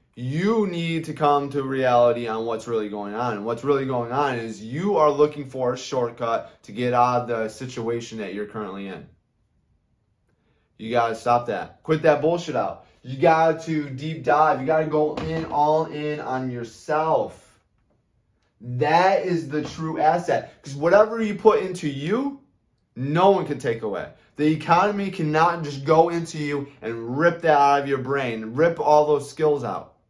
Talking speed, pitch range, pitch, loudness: 175 wpm, 120-160 Hz, 145 Hz, -22 LUFS